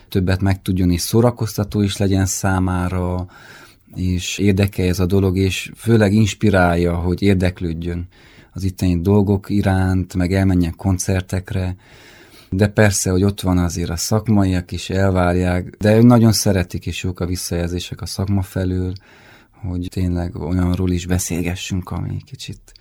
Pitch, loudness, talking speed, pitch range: 95 Hz, -18 LUFS, 135 wpm, 90-100 Hz